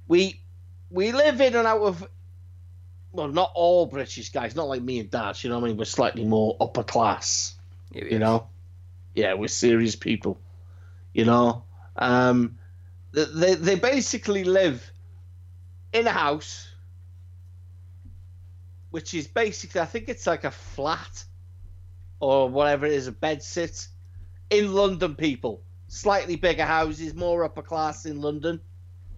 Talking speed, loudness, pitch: 145 wpm, -24 LUFS, 110 Hz